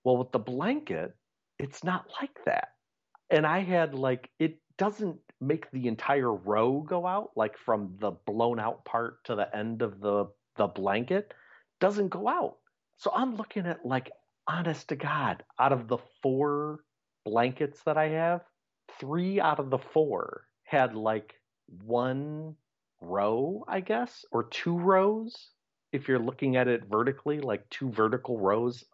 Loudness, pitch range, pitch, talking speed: -30 LUFS, 120-175 Hz, 140 Hz, 160 wpm